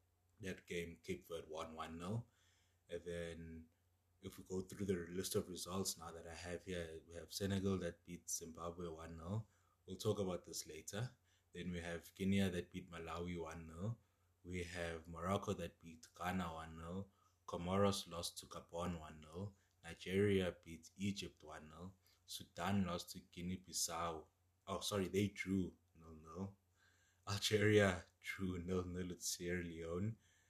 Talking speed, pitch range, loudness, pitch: 175 wpm, 85-95 Hz, -44 LUFS, 90 Hz